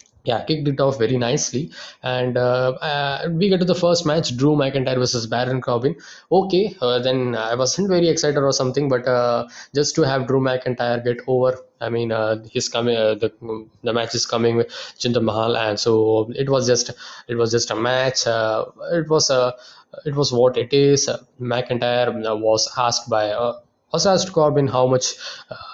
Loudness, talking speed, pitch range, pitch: -20 LUFS, 185 wpm, 120-140 Hz, 125 Hz